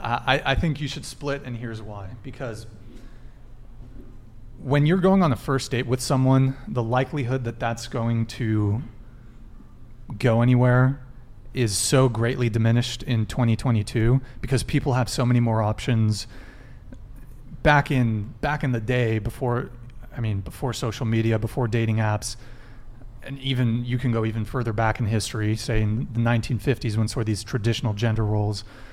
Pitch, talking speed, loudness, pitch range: 120 Hz, 160 wpm, -24 LUFS, 115-130 Hz